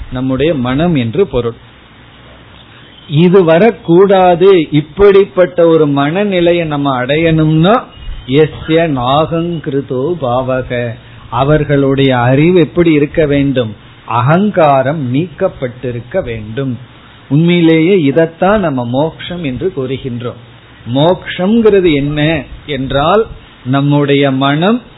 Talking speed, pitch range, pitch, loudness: 75 wpm, 130-170 Hz, 145 Hz, -11 LUFS